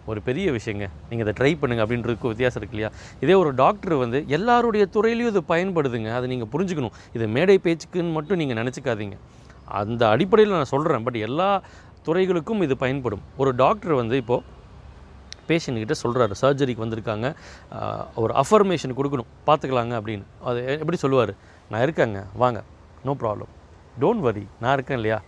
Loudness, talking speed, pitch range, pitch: -23 LUFS, 150 wpm, 110-160 Hz, 125 Hz